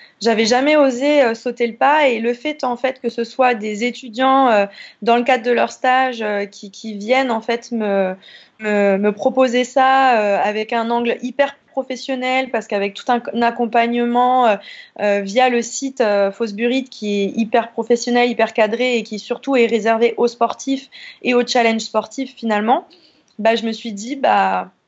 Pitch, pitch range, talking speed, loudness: 240 Hz, 225-260 Hz, 190 wpm, -17 LUFS